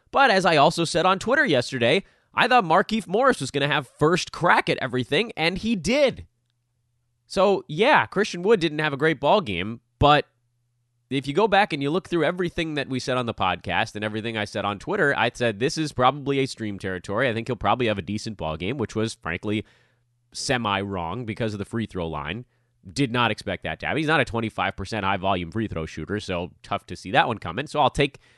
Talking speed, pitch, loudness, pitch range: 230 wpm, 120 Hz, -23 LUFS, 105-150 Hz